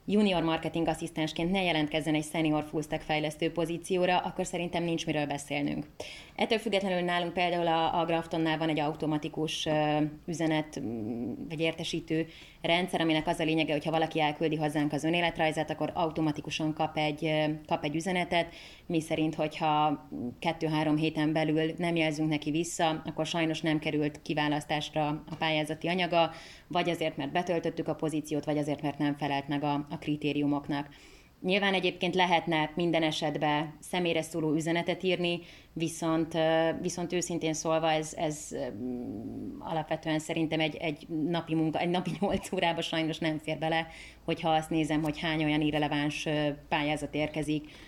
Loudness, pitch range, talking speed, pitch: -30 LUFS, 150-170 Hz, 150 wpm, 160 Hz